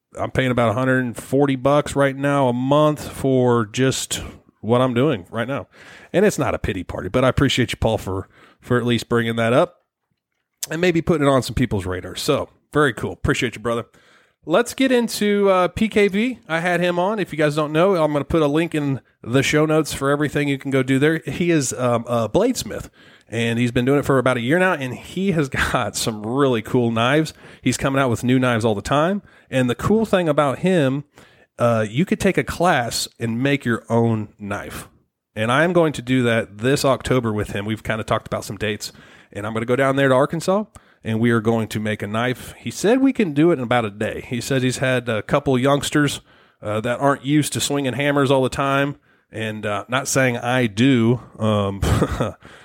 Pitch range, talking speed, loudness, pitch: 115-145 Hz, 225 wpm, -20 LUFS, 130 Hz